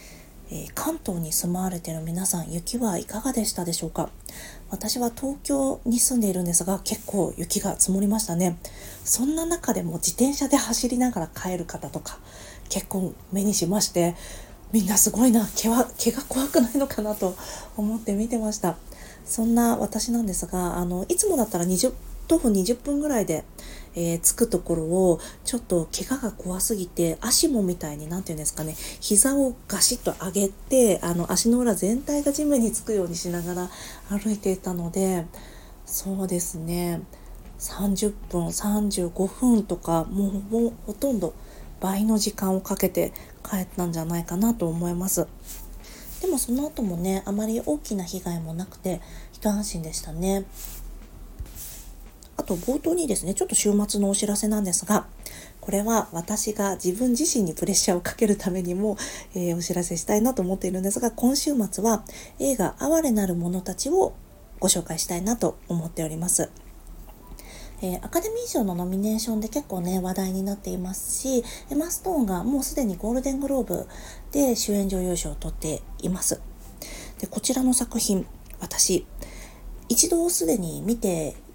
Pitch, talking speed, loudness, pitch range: 195 Hz, 325 characters per minute, -25 LUFS, 175-235 Hz